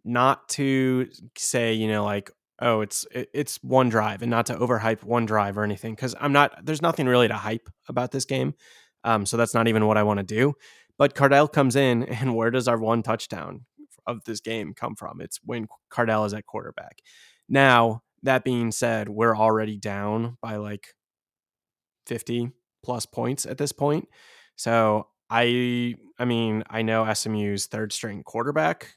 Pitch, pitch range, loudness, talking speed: 115 Hz, 110-130 Hz, -24 LUFS, 180 wpm